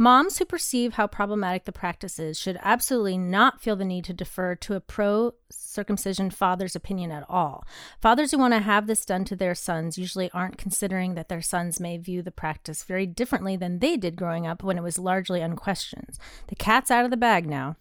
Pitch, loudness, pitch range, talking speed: 190 Hz, -25 LUFS, 180-215 Hz, 210 wpm